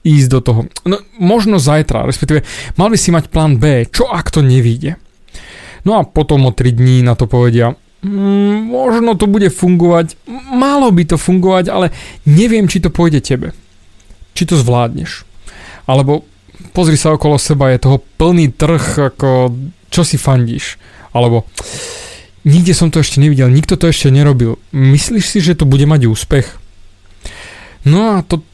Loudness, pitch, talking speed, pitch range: -11 LUFS, 150 Hz, 160 wpm, 125-180 Hz